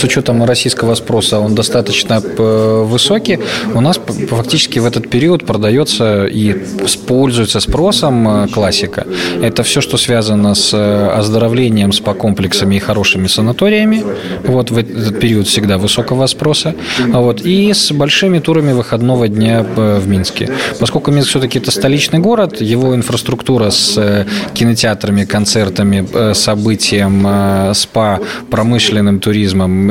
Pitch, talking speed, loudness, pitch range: 115 Hz, 120 wpm, -11 LUFS, 105-125 Hz